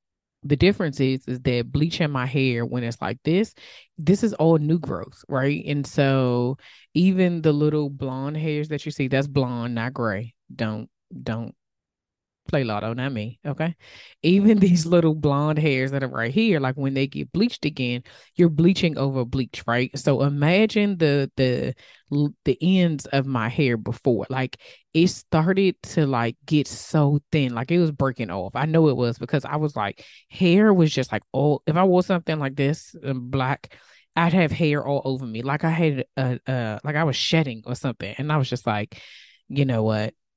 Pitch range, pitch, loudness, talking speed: 125-160 Hz, 140 Hz, -23 LUFS, 190 wpm